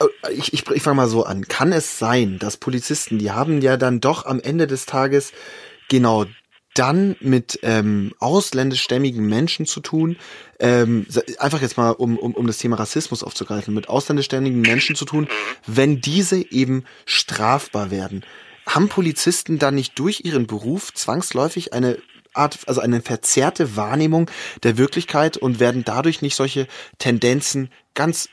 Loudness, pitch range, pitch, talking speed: -19 LUFS, 115-150 Hz, 130 Hz, 155 wpm